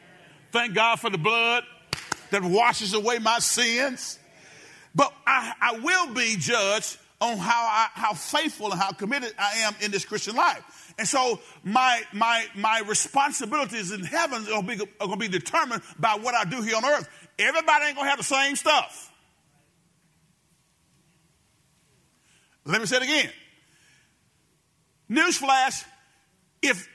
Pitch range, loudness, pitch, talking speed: 200-255 Hz, -24 LUFS, 225 Hz, 145 wpm